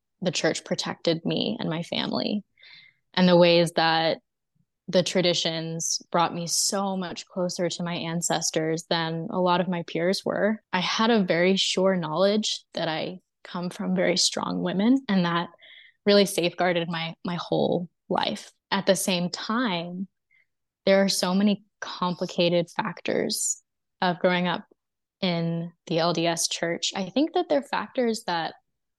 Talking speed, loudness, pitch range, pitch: 150 wpm, -25 LUFS, 170-195 Hz, 180 Hz